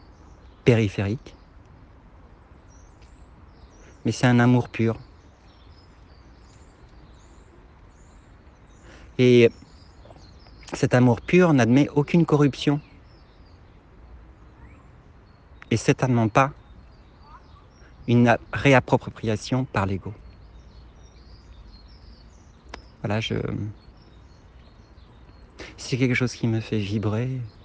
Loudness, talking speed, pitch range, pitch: -22 LUFS, 65 wpm, 85-115 Hz, 100 Hz